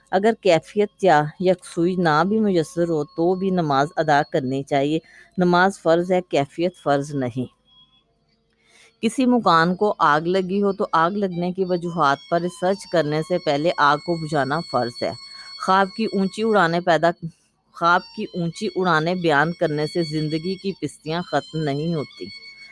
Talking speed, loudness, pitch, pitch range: 155 wpm, -21 LUFS, 170 Hz, 150-185 Hz